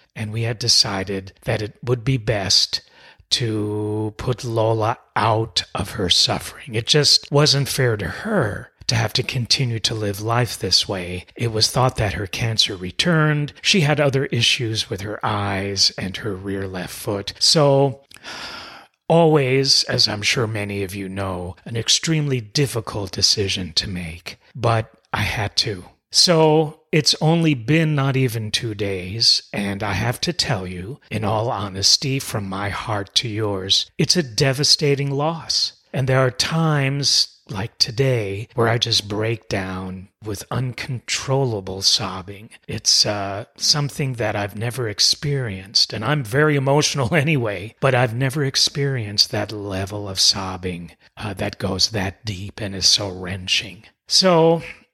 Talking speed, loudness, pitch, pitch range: 150 wpm, -19 LUFS, 115 Hz, 100-135 Hz